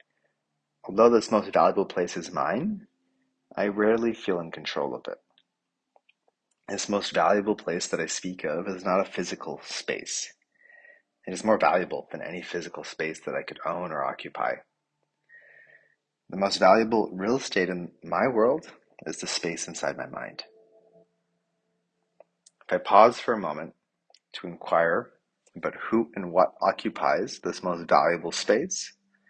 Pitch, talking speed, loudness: 190 Hz, 145 wpm, -26 LUFS